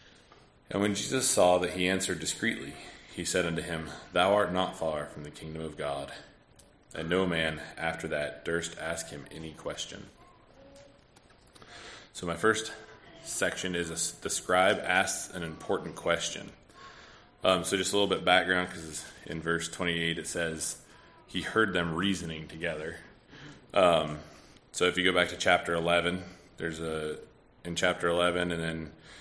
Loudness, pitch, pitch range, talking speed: -30 LUFS, 85 Hz, 80-90 Hz, 160 wpm